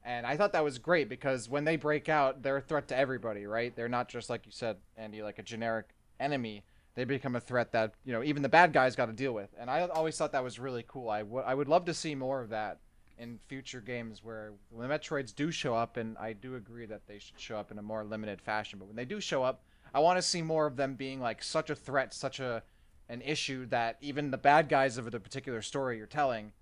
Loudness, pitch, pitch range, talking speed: -33 LUFS, 125 Hz, 115-140 Hz, 265 wpm